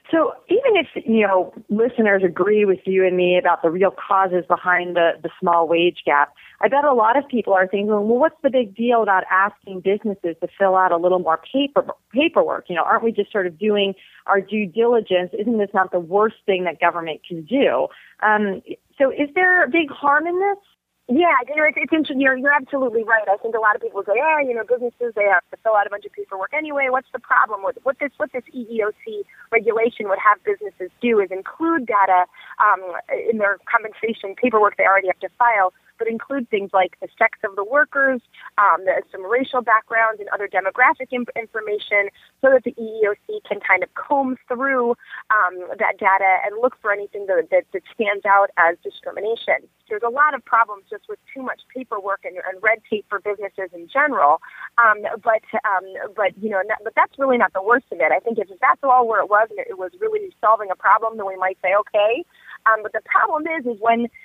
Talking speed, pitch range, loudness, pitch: 220 wpm, 195-265 Hz, -19 LUFS, 220 Hz